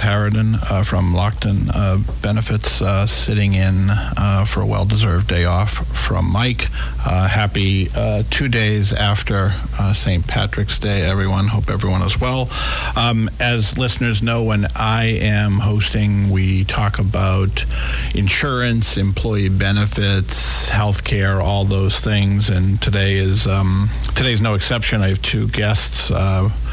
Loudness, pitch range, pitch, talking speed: -17 LUFS, 95-110 Hz, 100 Hz, 145 wpm